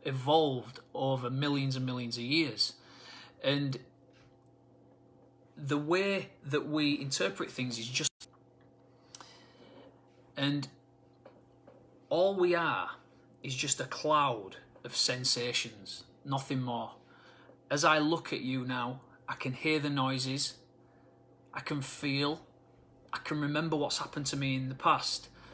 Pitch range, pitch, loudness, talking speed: 130-145 Hz, 130 Hz, -32 LUFS, 120 wpm